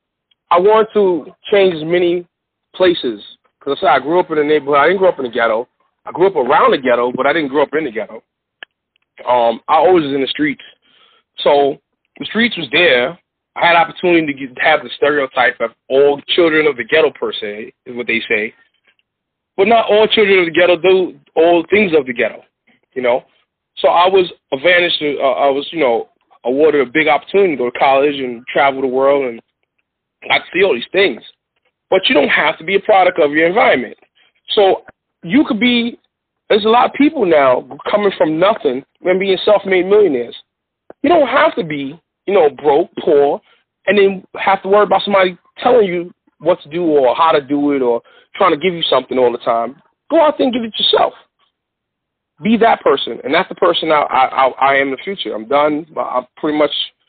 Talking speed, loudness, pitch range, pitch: 210 wpm, -14 LUFS, 140-205 Hz, 175 Hz